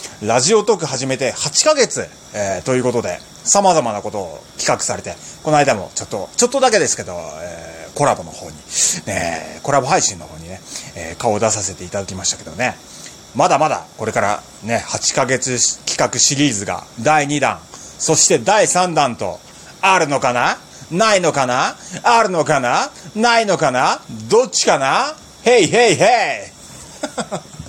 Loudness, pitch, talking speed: -16 LUFS, 125 Hz, 315 characters per minute